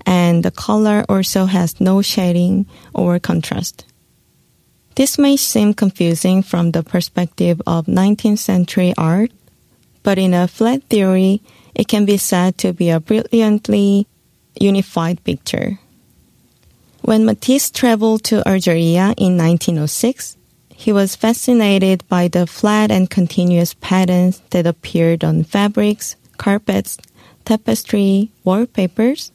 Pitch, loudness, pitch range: 195 Hz, -15 LUFS, 180-215 Hz